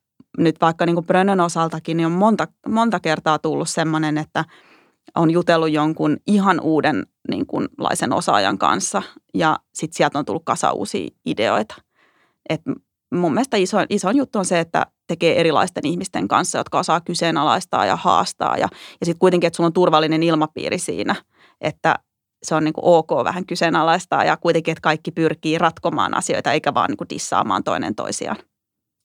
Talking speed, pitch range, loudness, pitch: 165 wpm, 160-180 Hz, -19 LUFS, 165 Hz